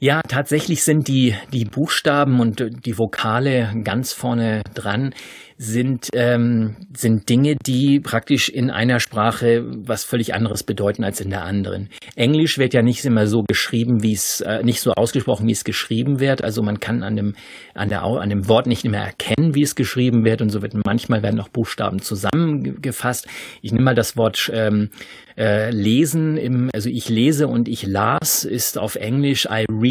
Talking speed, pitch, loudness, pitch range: 185 wpm, 115 Hz, -19 LUFS, 110-130 Hz